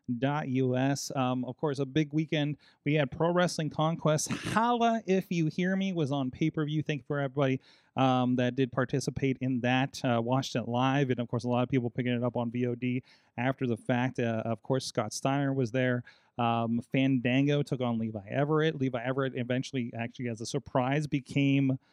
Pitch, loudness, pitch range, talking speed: 130 Hz, -30 LUFS, 125-145 Hz, 200 wpm